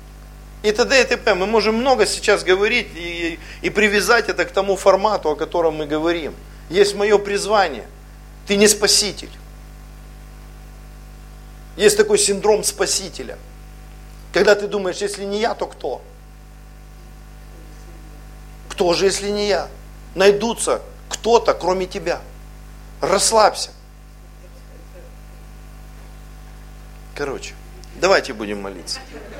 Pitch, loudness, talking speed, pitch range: 200 Hz, -18 LUFS, 105 wpm, 180-215 Hz